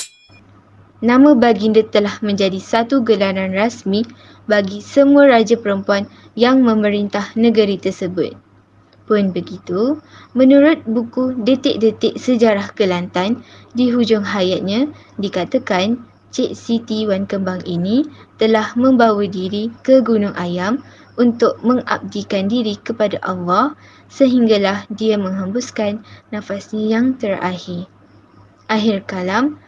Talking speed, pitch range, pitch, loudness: 100 wpm, 195-240 Hz, 215 Hz, -16 LUFS